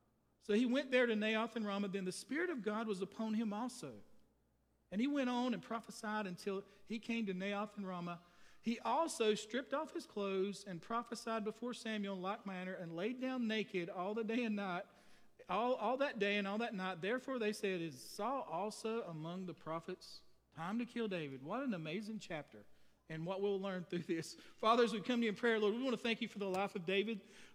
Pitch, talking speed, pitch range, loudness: 210 Hz, 220 wpm, 185-230 Hz, -40 LUFS